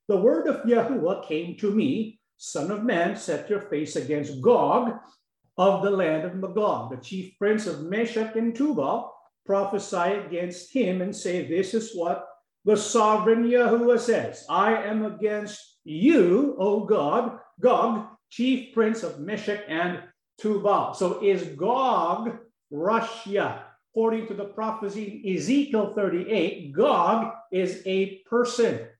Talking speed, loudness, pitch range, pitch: 140 wpm, -25 LUFS, 185-225 Hz, 210 Hz